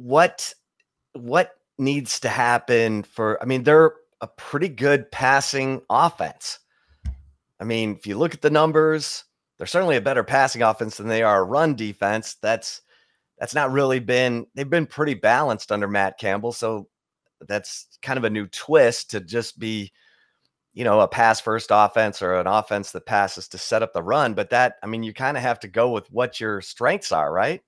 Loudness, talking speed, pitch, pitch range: -21 LUFS, 190 wpm, 115 Hz, 105-135 Hz